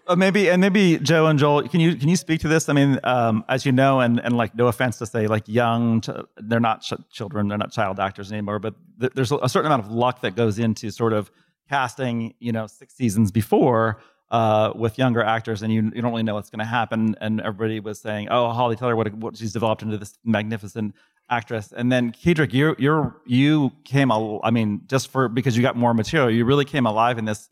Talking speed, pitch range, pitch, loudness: 240 wpm, 110-130 Hz, 115 Hz, -21 LUFS